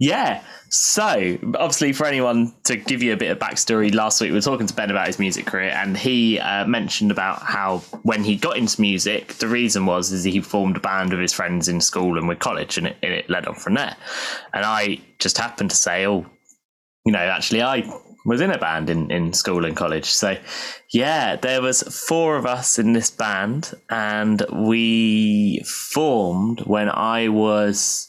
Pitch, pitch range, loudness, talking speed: 105 Hz, 95-115 Hz, -20 LUFS, 200 wpm